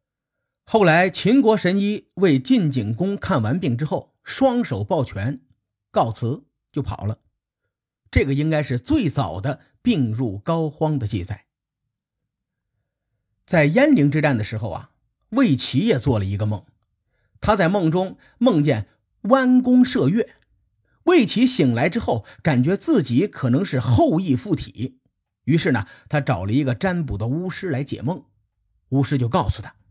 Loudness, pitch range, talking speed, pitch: -20 LUFS, 110-165 Hz, 210 characters per minute, 130 Hz